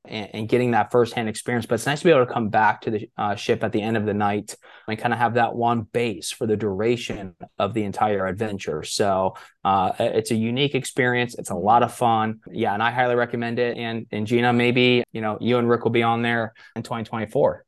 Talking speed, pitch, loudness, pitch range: 240 wpm, 115 Hz, -22 LUFS, 110-120 Hz